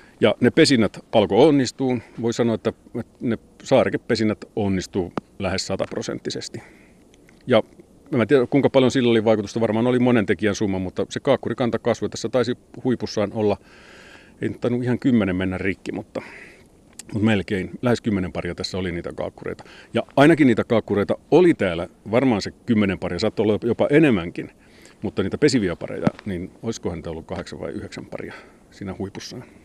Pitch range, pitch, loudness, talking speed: 95-120 Hz, 110 Hz, -21 LUFS, 160 wpm